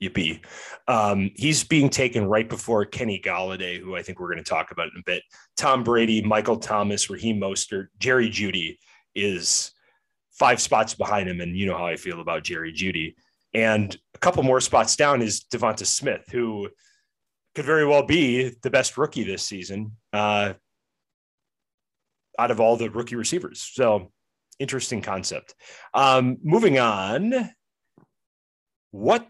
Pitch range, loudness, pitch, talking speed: 95-130 Hz, -23 LUFS, 110 Hz, 155 wpm